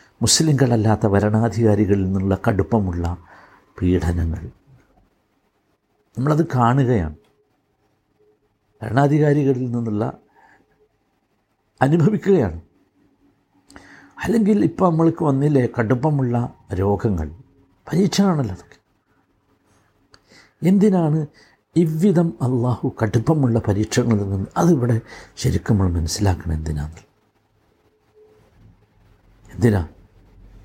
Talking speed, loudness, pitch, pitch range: 60 wpm, -19 LUFS, 110 Hz, 100-140 Hz